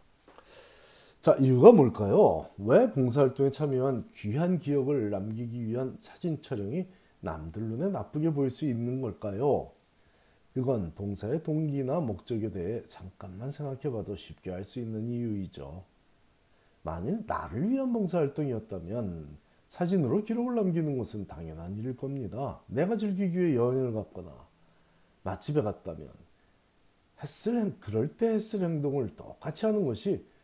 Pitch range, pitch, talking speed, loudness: 105-155 Hz, 130 Hz, 290 characters per minute, -29 LUFS